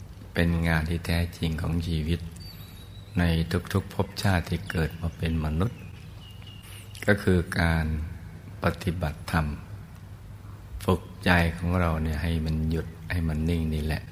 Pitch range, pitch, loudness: 80-95 Hz, 85 Hz, -28 LUFS